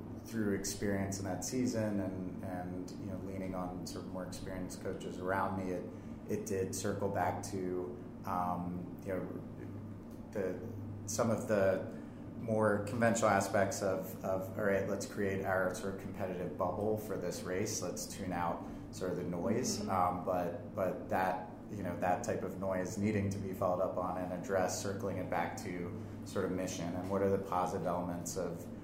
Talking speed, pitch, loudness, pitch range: 180 wpm, 95 Hz, -37 LUFS, 90-105 Hz